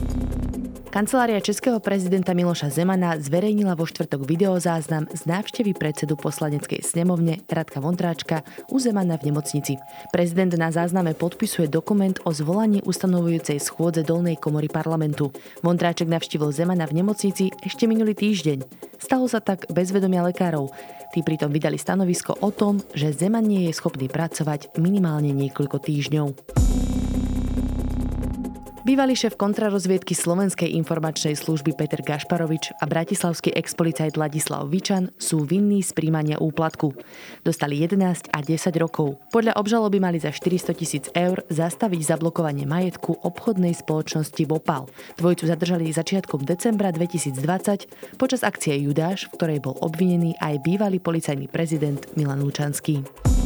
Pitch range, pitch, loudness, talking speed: 155-185 Hz, 165 Hz, -23 LUFS, 130 wpm